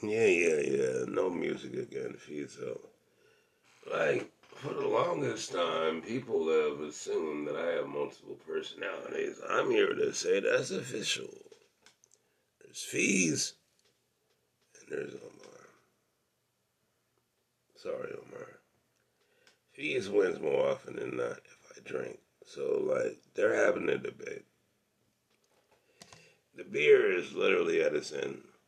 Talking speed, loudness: 115 wpm, -32 LUFS